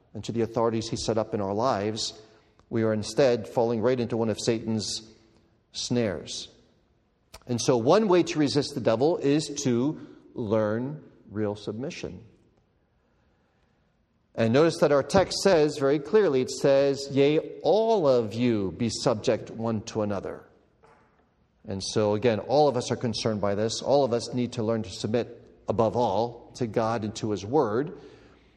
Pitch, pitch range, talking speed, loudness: 115 Hz, 110-135 Hz, 165 wpm, -26 LUFS